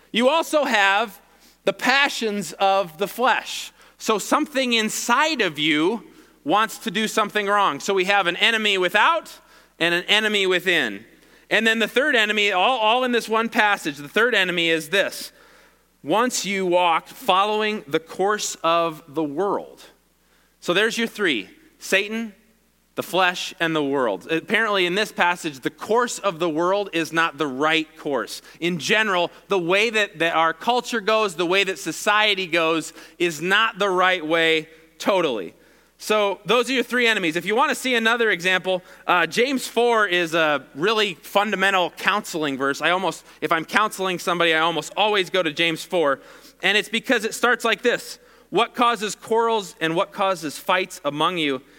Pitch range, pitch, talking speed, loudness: 170-225 Hz, 195 Hz, 170 wpm, -21 LUFS